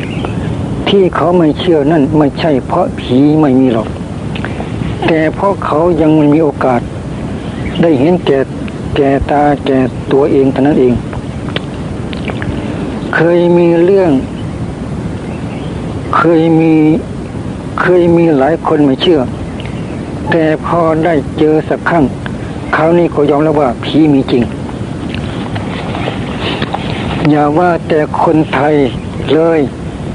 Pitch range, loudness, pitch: 140-165 Hz, -12 LUFS, 155 Hz